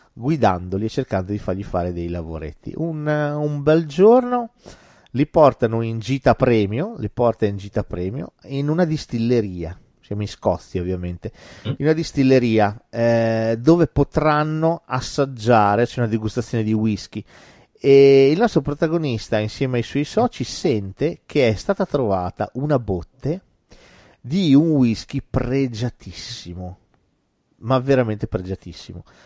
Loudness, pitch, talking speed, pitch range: -20 LUFS, 120 Hz, 130 wpm, 105-145 Hz